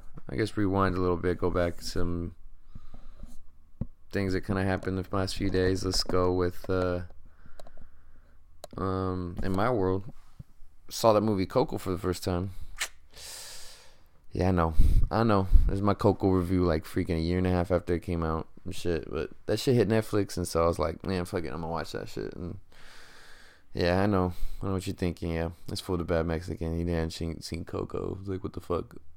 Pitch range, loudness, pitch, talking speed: 80-95 Hz, -30 LUFS, 90 Hz, 205 wpm